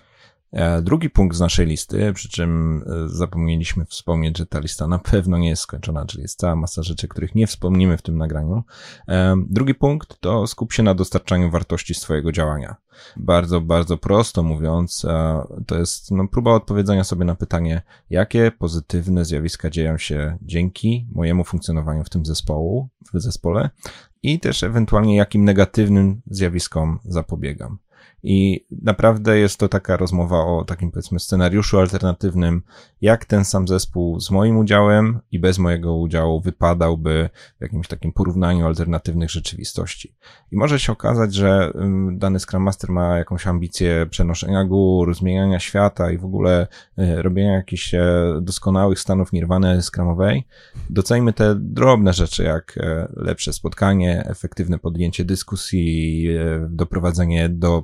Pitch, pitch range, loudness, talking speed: 90 Hz, 85-100 Hz, -19 LUFS, 140 wpm